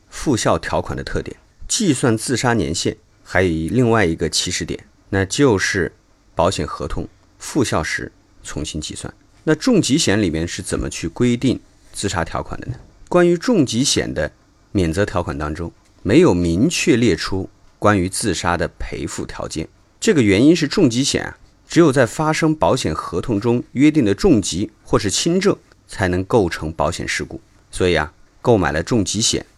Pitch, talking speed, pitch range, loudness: 100 Hz, 255 characters per minute, 90-125 Hz, -18 LUFS